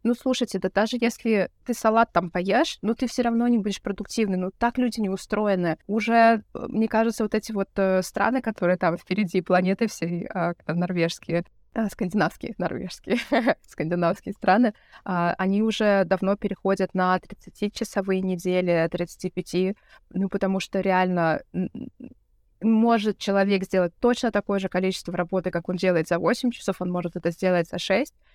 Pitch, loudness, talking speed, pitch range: 195 Hz, -24 LUFS, 160 wpm, 180-225 Hz